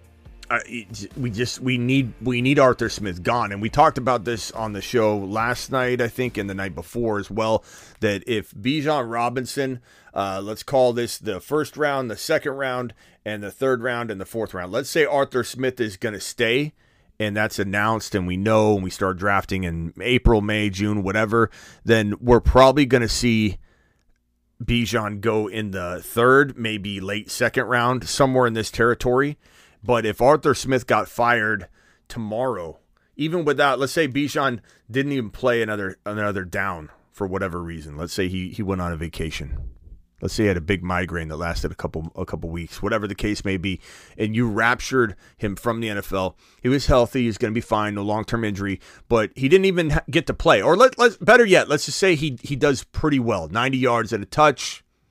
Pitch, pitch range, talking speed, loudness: 110 Hz, 95-125 Hz, 200 wpm, -22 LUFS